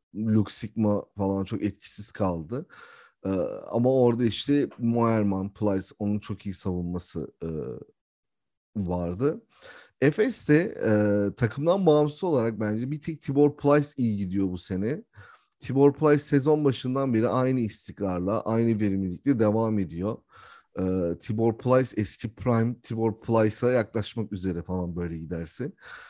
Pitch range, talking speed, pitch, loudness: 95-130 Hz, 125 wpm, 110 Hz, -26 LUFS